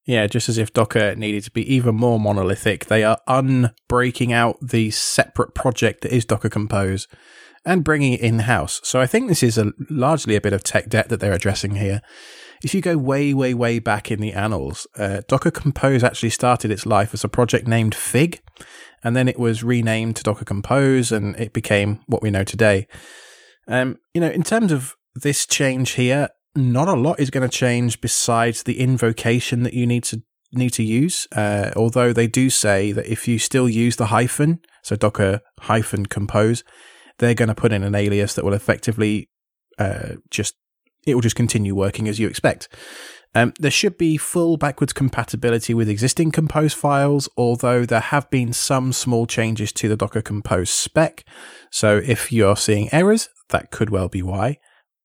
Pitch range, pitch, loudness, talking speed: 105-130 Hz, 115 Hz, -19 LUFS, 190 wpm